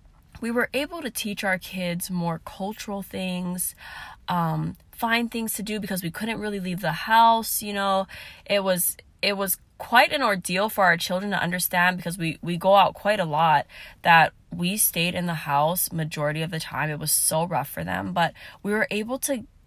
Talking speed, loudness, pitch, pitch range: 200 wpm, -24 LUFS, 185 Hz, 170-210 Hz